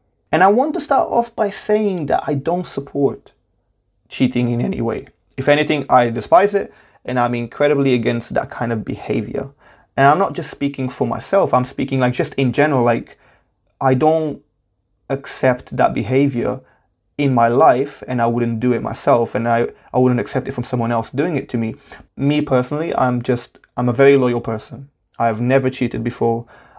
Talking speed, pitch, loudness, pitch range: 190 wpm, 130 Hz, -18 LUFS, 120-140 Hz